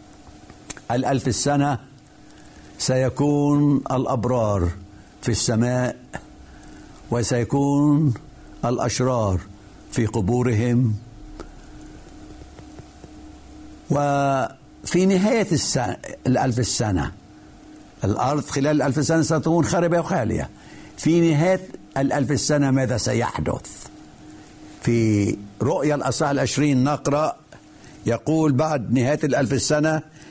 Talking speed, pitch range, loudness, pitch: 75 wpm, 115-150 Hz, -21 LUFS, 130 Hz